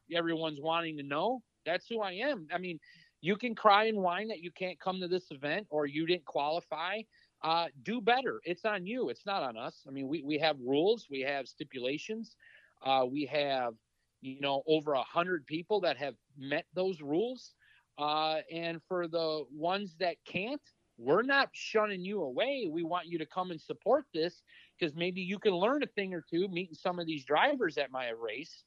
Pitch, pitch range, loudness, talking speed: 170 Hz, 150-200 Hz, -34 LUFS, 200 wpm